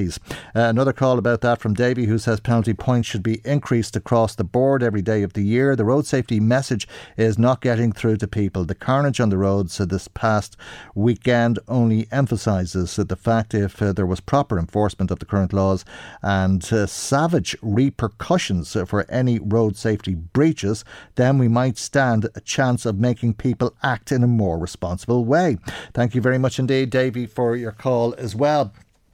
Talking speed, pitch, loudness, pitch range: 185 wpm, 115 Hz, -21 LUFS, 100-125 Hz